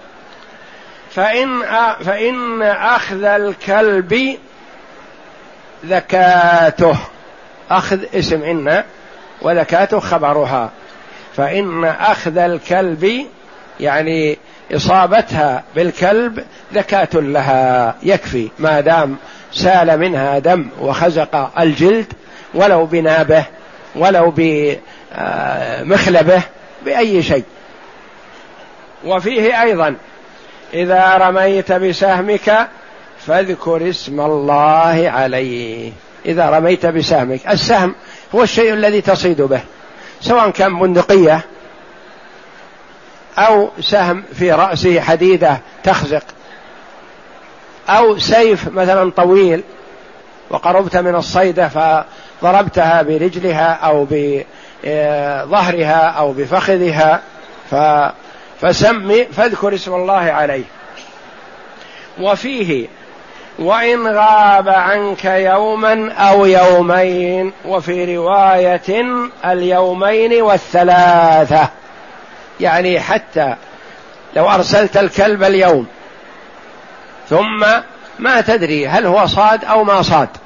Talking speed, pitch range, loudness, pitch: 75 wpm, 160-200 Hz, -13 LUFS, 180 Hz